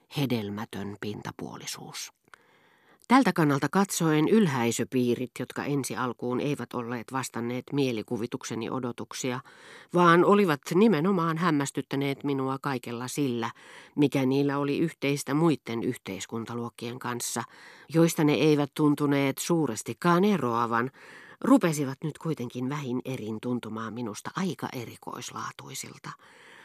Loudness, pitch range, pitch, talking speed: -28 LUFS, 120-150 Hz, 135 Hz, 95 wpm